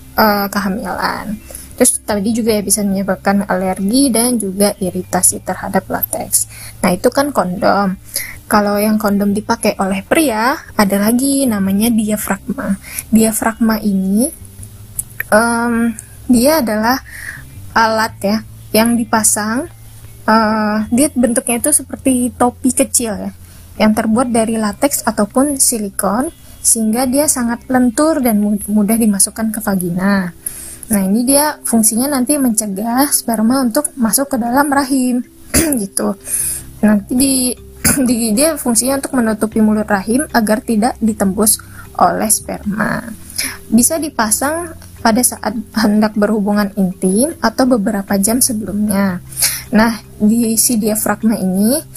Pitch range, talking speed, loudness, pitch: 205-250 Hz, 115 wpm, -14 LUFS, 220 Hz